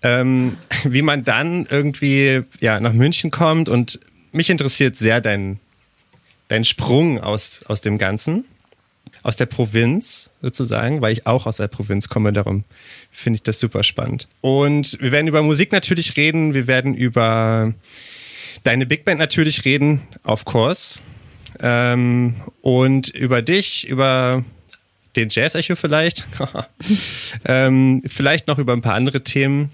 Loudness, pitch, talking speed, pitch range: -17 LUFS, 130 Hz, 145 wpm, 115-145 Hz